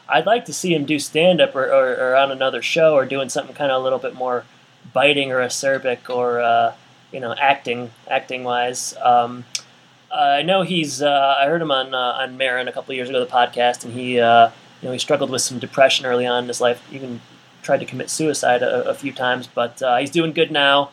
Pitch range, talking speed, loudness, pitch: 120-140 Hz, 230 wpm, -19 LUFS, 130 Hz